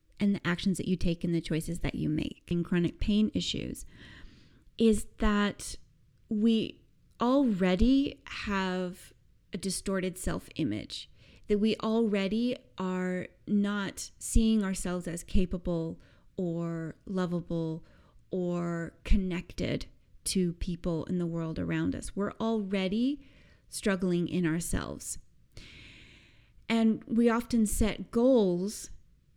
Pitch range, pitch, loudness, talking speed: 170-215 Hz, 185 Hz, -31 LUFS, 110 wpm